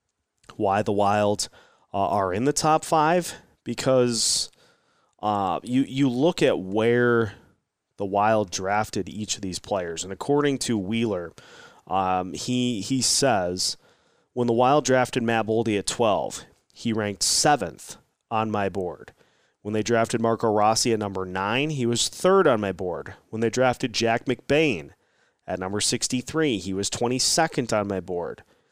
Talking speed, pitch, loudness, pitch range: 155 wpm, 115 Hz, -24 LUFS, 100-130 Hz